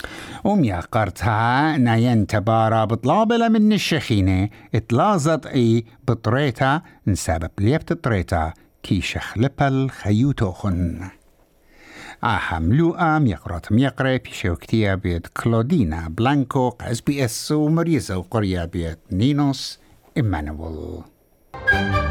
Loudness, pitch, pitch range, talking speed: -20 LUFS, 115 Hz, 95-135 Hz, 85 wpm